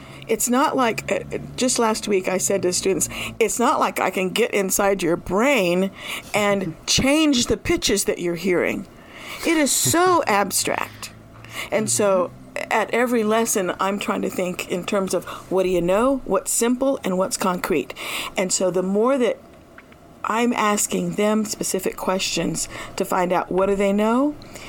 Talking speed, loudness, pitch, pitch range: 165 wpm, -21 LUFS, 200 Hz, 185-240 Hz